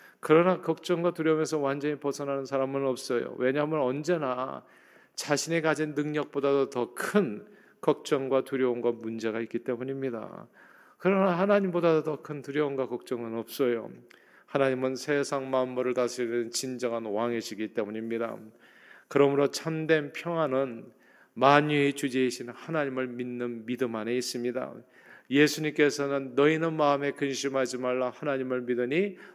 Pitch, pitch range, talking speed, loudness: 135 Hz, 125-150 Hz, 330 characters per minute, -28 LUFS